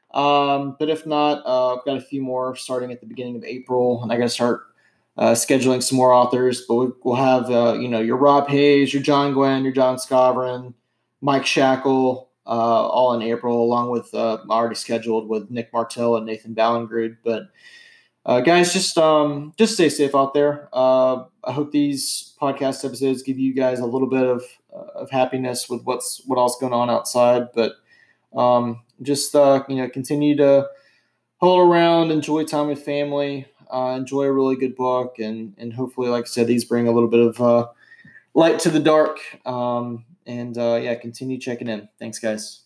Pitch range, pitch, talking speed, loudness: 120-140 Hz, 130 Hz, 195 wpm, -20 LUFS